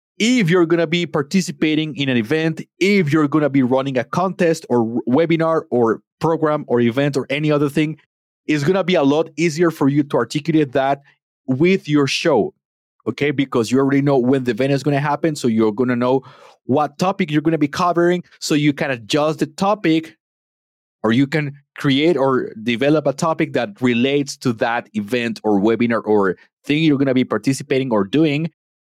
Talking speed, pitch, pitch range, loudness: 200 wpm, 145 Hz, 130-160 Hz, -18 LUFS